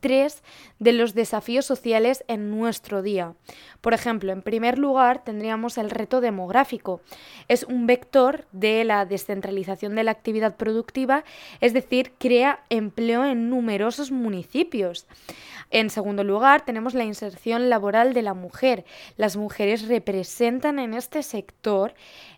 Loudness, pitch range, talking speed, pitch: -23 LUFS, 210-255 Hz, 135 wpm, 230 Hz